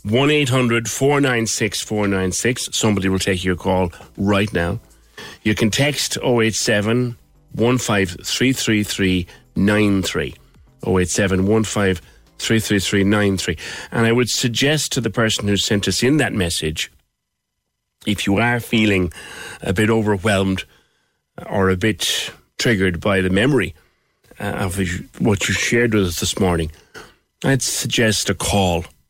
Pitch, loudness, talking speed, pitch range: 105 Hz, -18 LUFS, 115 wpm, 95-115 Hz